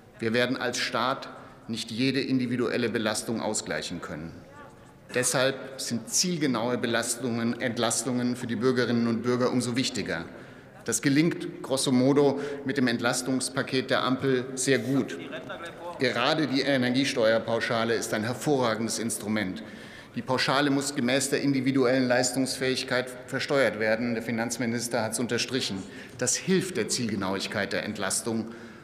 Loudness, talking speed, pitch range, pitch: -27 LUFS, 125 wpm, 120-135 Hz, 125 Hz